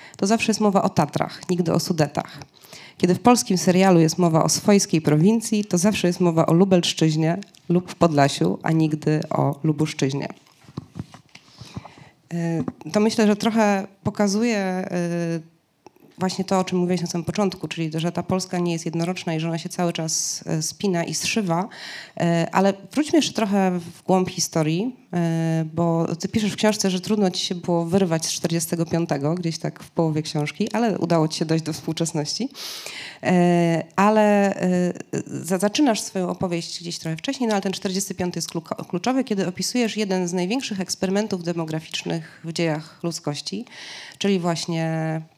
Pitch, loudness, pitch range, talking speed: 175 Hz, -22 LUFS, 165-195 Hz, 155 wpm